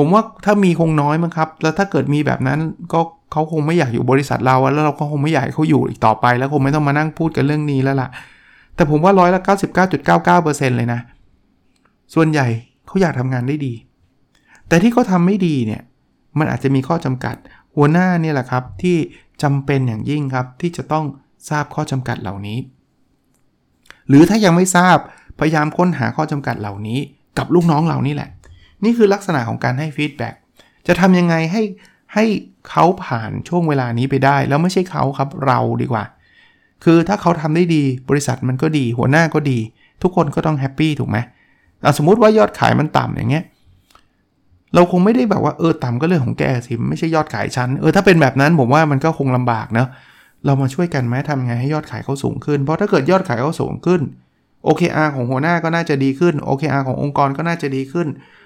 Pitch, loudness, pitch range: 150 Hz, -16 LUFS, 130-165 Hz